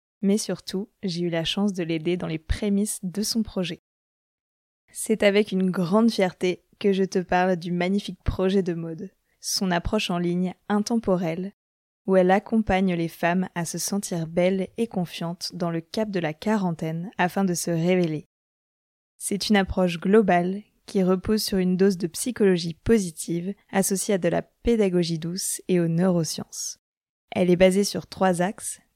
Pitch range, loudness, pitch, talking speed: 175-200 Hz, -24 LUFS, 185 Hz, 170 wpm